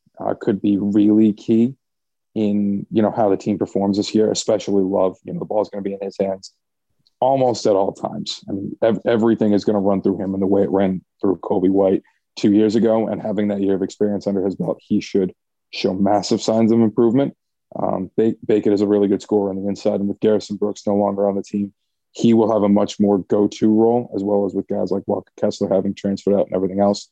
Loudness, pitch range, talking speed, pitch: -19 LUFS, 100-110 Hz, 240 wpm, 100 Hz